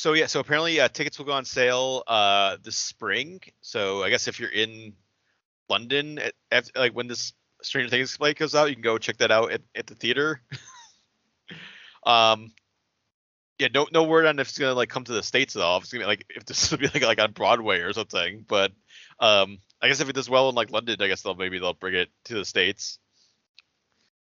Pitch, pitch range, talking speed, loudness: 125 Hz, 110-145 Hz, 225 wpm, -24 LUFS